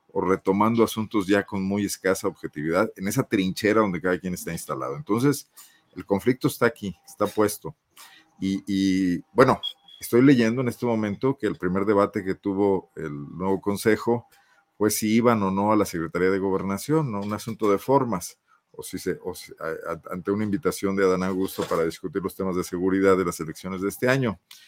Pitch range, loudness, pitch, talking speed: 95-110 Hz, -24 LUFS, 100 Hz, 190 wpm